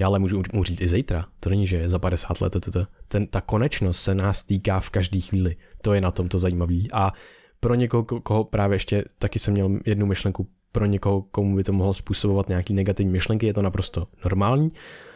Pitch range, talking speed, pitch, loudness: 95-100 Hz, 220 wpm, 95 Hz, -24 LUFS